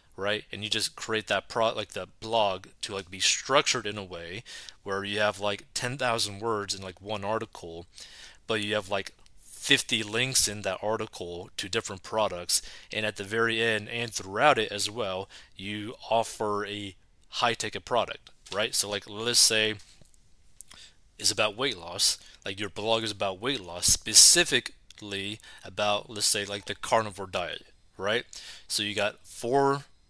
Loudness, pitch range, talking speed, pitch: -27 LUFS, 100-115 Hz, 170 wpm, 105 Hz